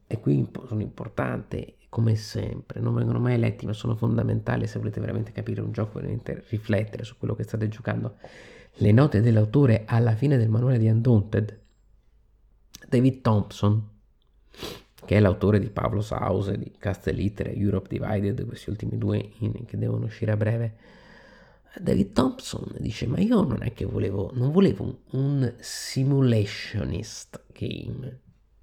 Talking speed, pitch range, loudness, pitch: 145 wpm, 105-120 Hz, -26 LUFS, 110 Hz